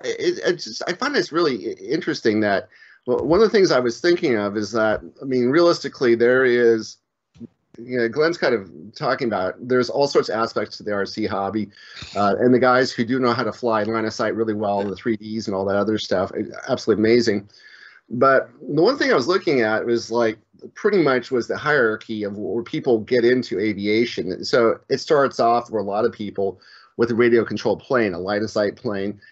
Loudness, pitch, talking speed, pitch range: -20 LUFS, 115 Hz, 220 wpm, 105-125 Hz